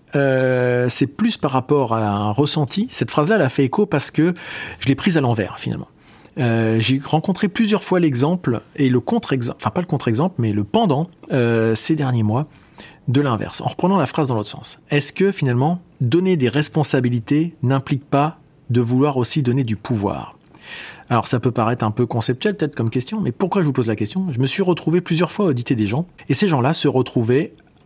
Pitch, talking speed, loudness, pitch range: 140 Hz, 205 wpm, -19 LUFS, 125-160 Hz